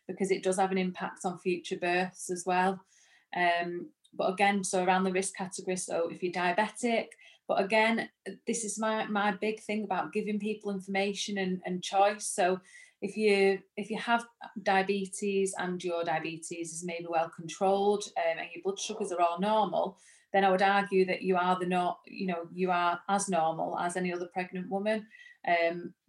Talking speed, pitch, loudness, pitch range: 185 wpm, 190 Hz, -31 LUFS, 180-205 Hz